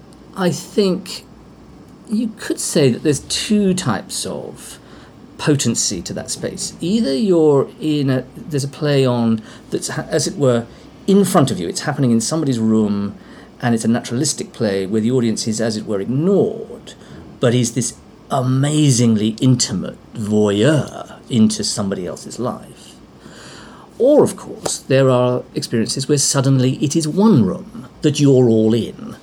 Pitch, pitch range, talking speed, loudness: 135 Hz, 115-155 Hz, 150 wpm, -17 LUFS